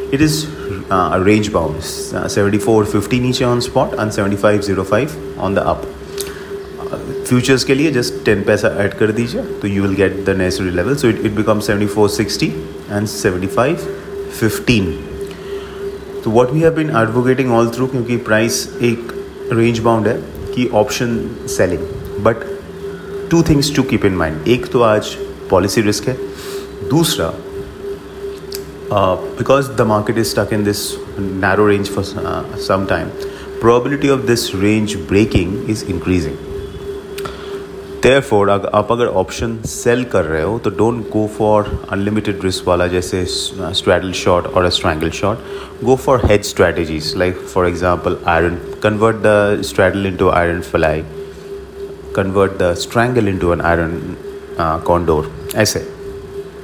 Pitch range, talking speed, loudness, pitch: 100-135 Hz, 145 wpm, -16 LUFS, 110 Hz